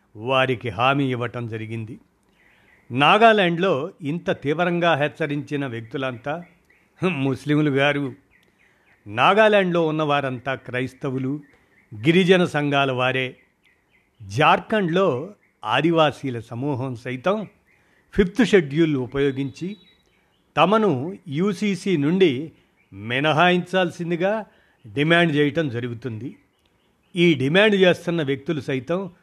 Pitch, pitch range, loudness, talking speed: 145 Hz, 130-175 Hz, -21 LUFS, 75 wpm